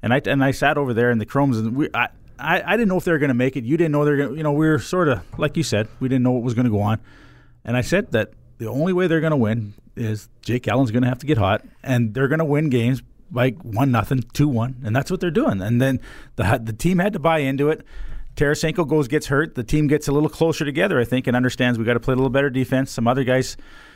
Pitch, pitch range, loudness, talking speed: 130 Hz, 120-150 Hz, -20 LUFS, 300 wpm